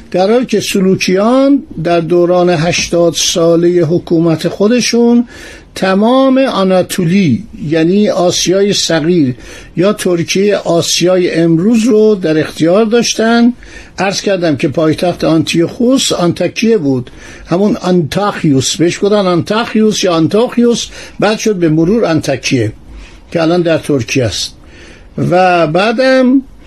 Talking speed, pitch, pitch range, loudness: 110 wpm, 180 Hz, 165-215 Hz, -11 LUFS